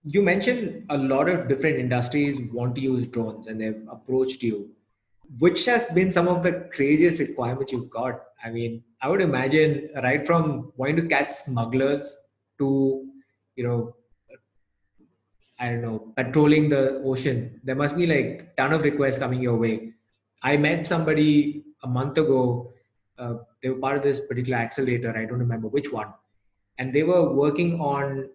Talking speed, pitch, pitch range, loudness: 165 wpm, 135 Hz, 120-150 Hz, -24 LUFS